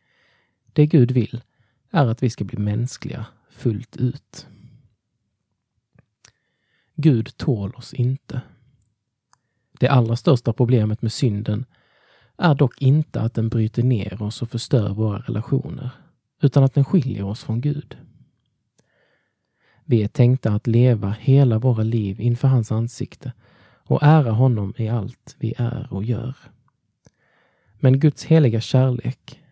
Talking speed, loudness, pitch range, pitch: 130 wpm, -20 LUFS, 110-135 Hz, 120 Hz